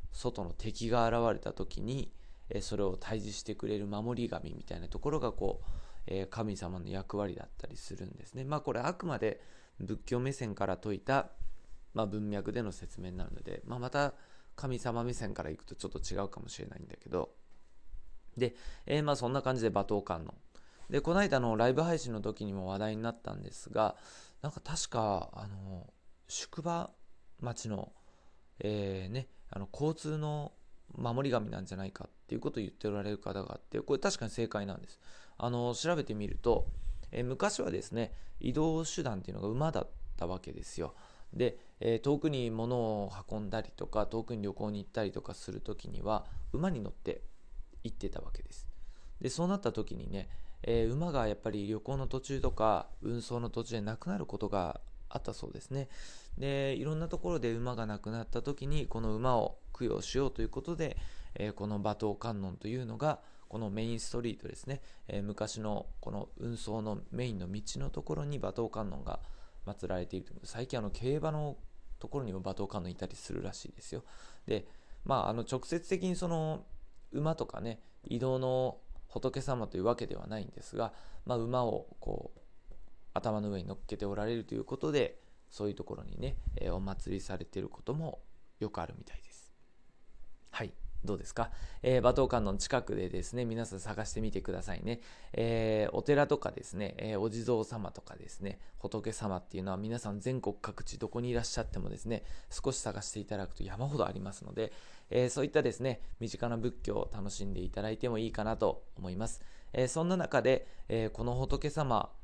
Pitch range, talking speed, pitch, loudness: 95-125 Hz, 365 characters per minute, 110 Hz, -37 LUFS